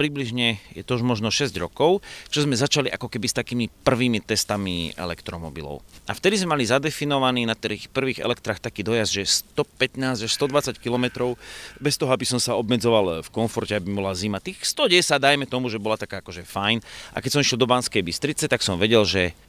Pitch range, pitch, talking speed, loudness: 105-130 Hz, 120 Hz, 190 wpm, -23 LUFS